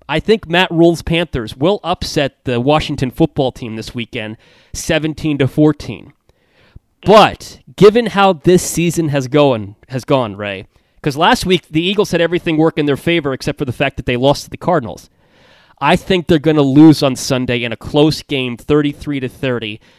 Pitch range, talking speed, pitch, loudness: 130-170 Hz, 185 wpm, 150 Hz, -14 LUFS